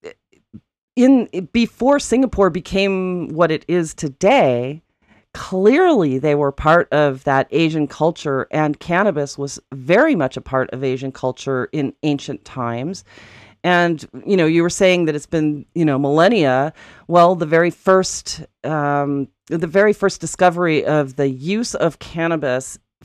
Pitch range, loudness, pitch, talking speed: 140-180 Hz, -17 LUFS, 155 Hz, 145 wpm